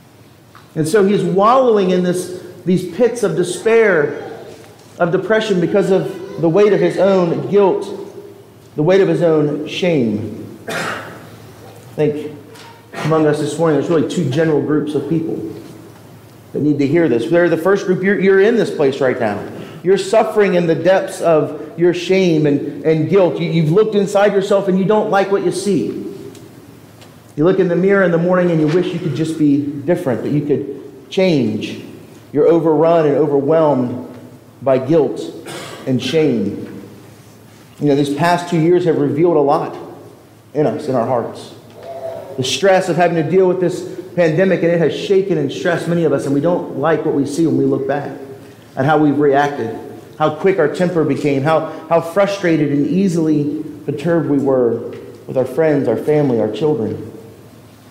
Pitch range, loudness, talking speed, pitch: 140-180 Hz, -15 LUFS, 180 wpm, 160 Hz